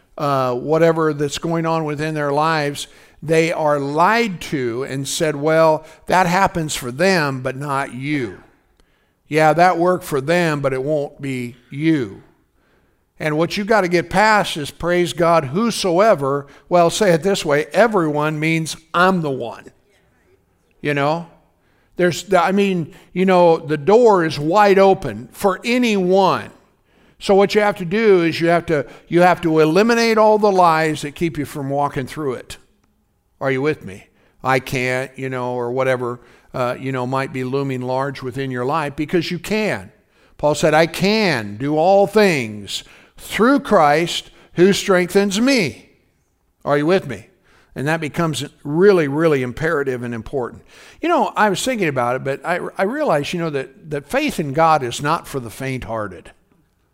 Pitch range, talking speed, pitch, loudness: 140-180 Hz, 170 wpm, 160 Hz, -18 LUFS